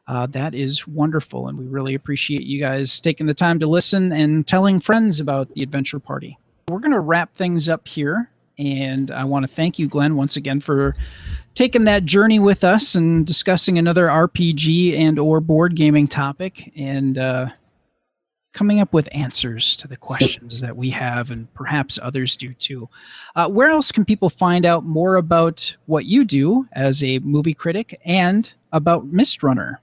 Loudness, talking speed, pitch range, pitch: -17 LUFS, 180 wpm, 135-175 Hz, 155 Hz